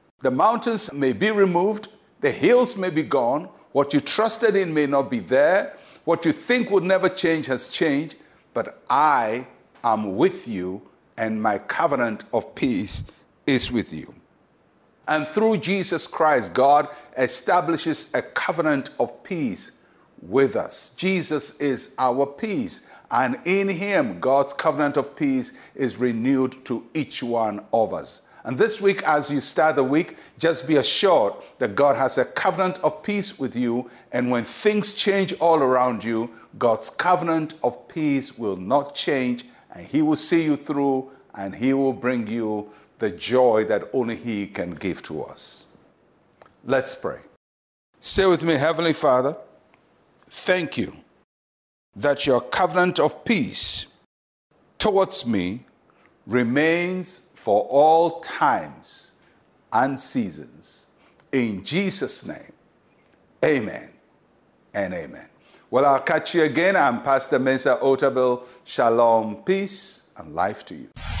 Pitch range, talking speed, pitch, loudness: 125-185 Hz, 140 wpm, 145 Hz, -22 LUFS